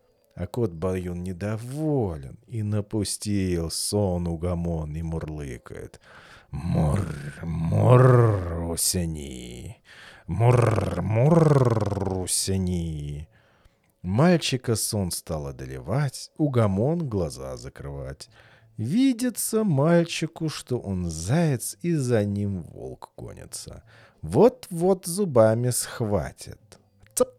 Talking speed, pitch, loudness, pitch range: 80 wpm, 105 Hz, -24 LUFS, 85-140 Hz